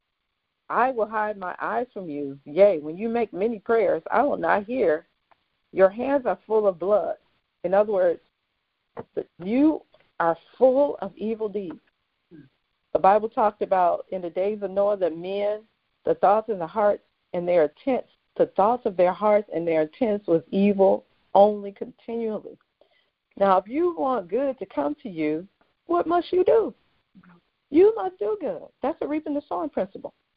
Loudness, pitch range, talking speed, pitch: -24 LUFS, 190-260 Hz, 170 wpm, 210 Hz